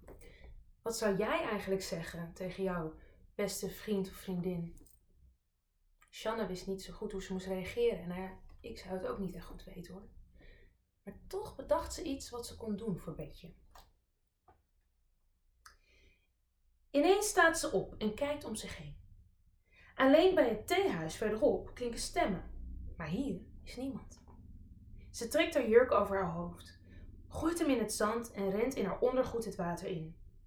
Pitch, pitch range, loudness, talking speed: 190 Hz, 145-235 Hz, -35 LUFS, 165 wpm